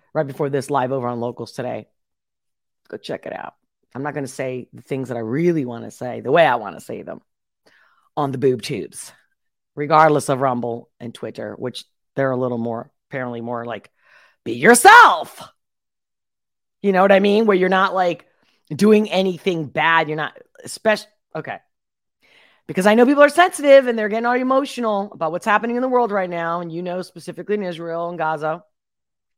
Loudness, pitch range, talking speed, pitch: -18 LUFS, 135-210 Hz, 195 wpm, 170 Hz